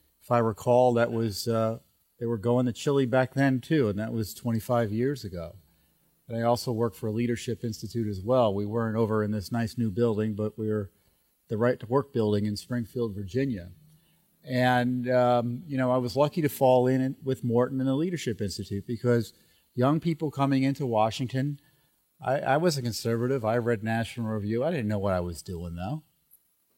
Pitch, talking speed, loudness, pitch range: 120 Hz, 195 wpm, -27 LUFS, 110-130 Hz